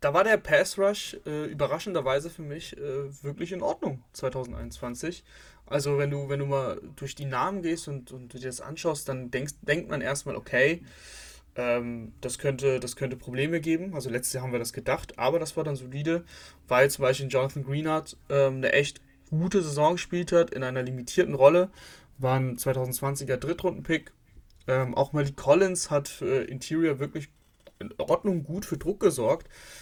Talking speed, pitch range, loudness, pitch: 180 wpm, 130-165 Hz, -28 LUFS, 140 Hz